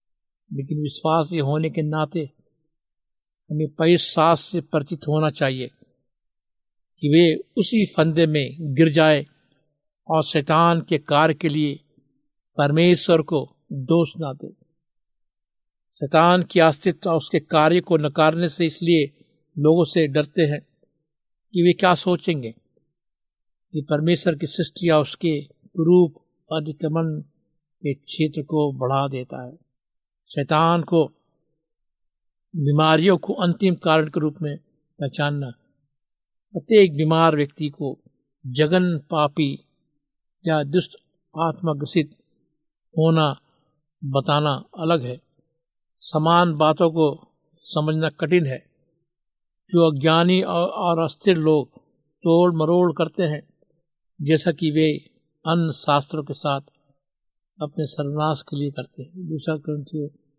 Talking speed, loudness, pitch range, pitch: 115 wpm, -21 LUFS, 145-165 Hz, 155 Hz